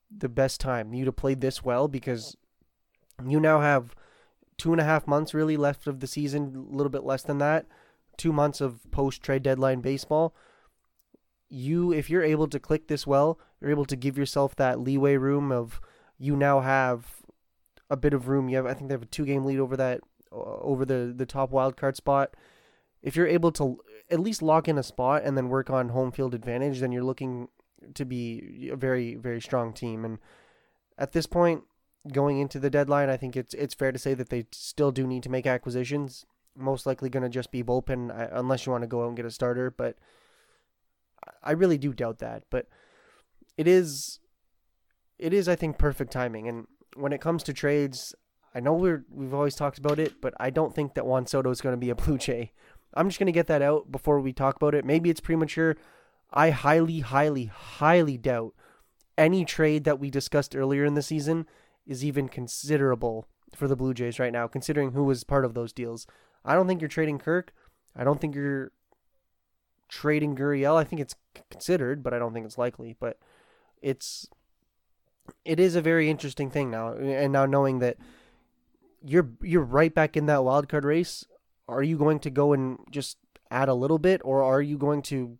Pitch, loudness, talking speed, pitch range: 140 Hz, -27 LUFS, 205 wpm, 130-150 Hz